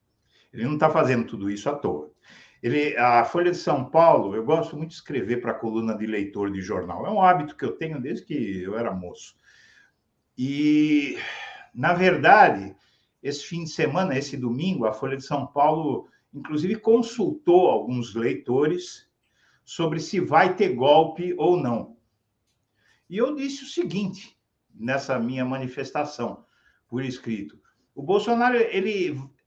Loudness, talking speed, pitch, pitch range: -23 LUFS, 155 wpm, 145 Hz, 120-185 Hz